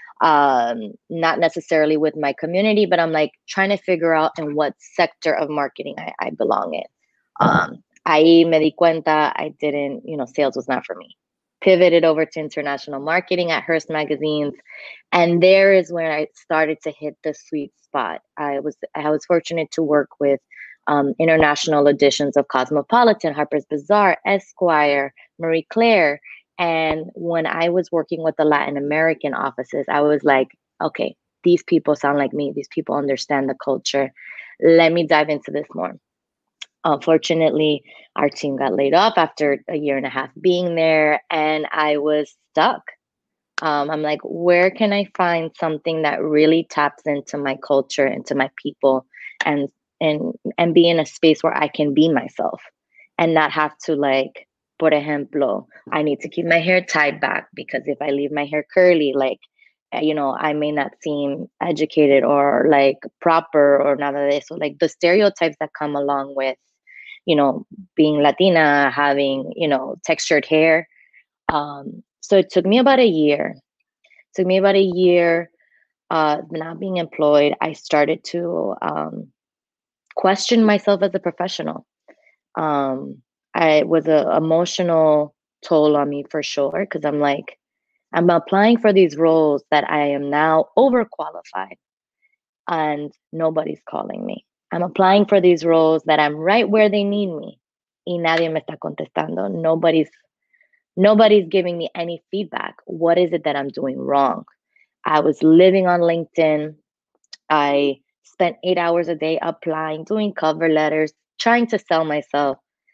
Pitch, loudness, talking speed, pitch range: 155 Hz, -18 LUFS, 160 wpm, 145-175 Hz